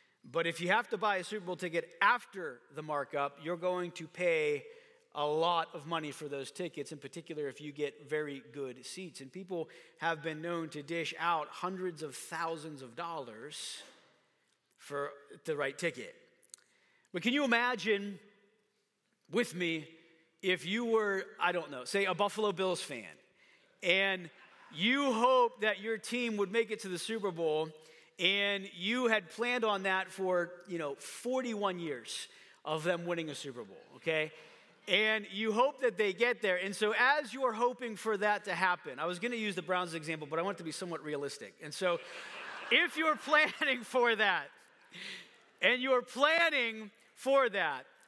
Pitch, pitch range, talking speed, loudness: 185 Hz, 160-225 Hz, 175 wpm, -33 LUFS